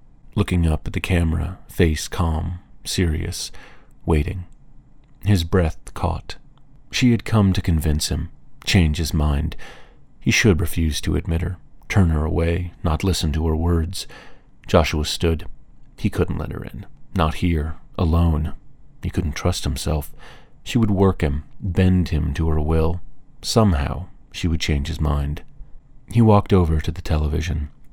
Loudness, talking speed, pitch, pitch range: -21 LUFS, 150 wpm, 85 Hz, 80-95 Hz